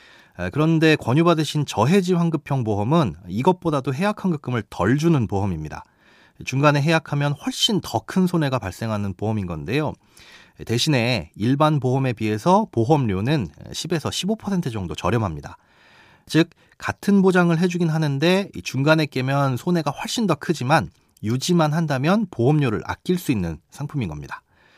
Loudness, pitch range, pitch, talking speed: -21 LUFS, 115-170 Hz, 145 Hz, 315 characters per minute